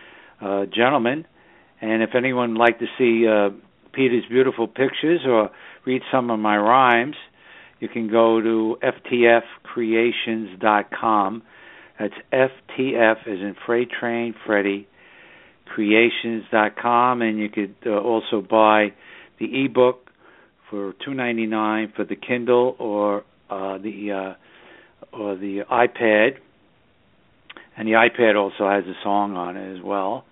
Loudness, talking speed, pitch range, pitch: -20 LUFS, 125 wpm, 105-120 Hz, 110 Hz